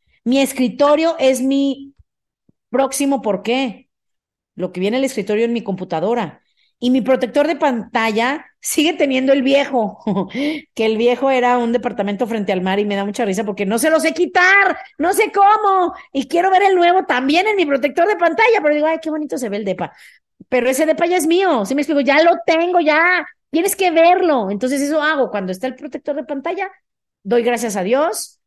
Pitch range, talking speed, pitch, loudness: 235-330 Hz, 205 wpm, 275 Hz, -16 LUFS